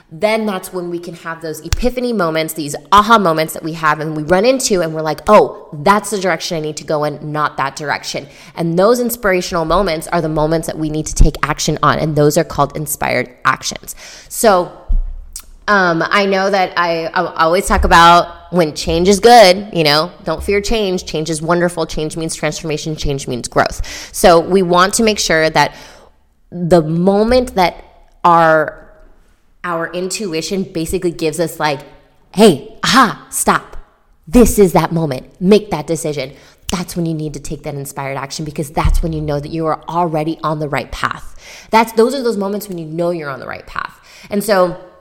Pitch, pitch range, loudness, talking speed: 165 Hz, 155-185 Hz, -14 LUFS, 195 wpm